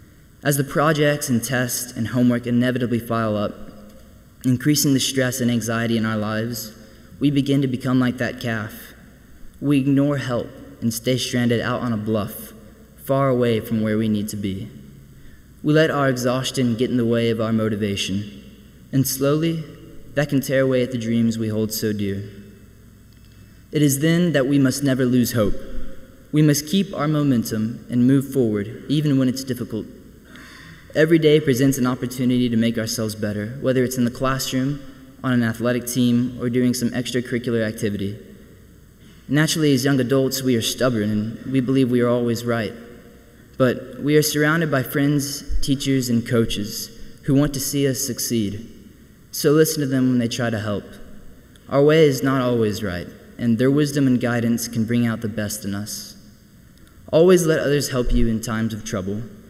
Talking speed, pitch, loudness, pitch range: 175 wpm, 125 Hz, -21 LUFS, 110-135 Hz